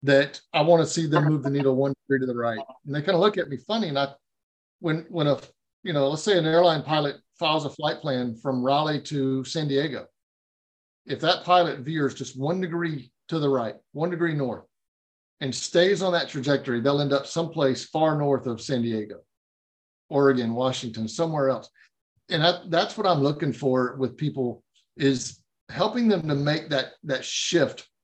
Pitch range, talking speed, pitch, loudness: 130-160 Hz, 195 wpm, 140 Hz, -25 LUFS